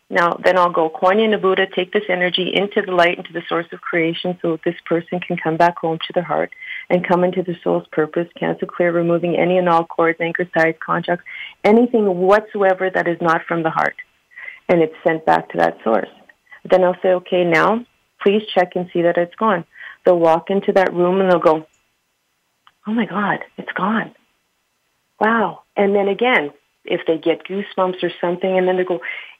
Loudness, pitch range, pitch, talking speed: -18 LUFS, 170-190 Hz, 180 Hz, 200 wpm